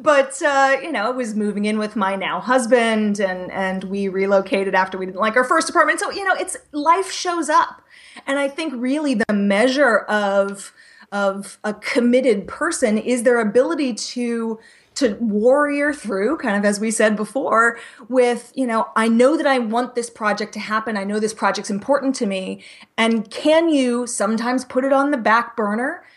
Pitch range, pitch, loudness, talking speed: 210-275 Hz, 235 Hz, -19 LUFS, 190 wpm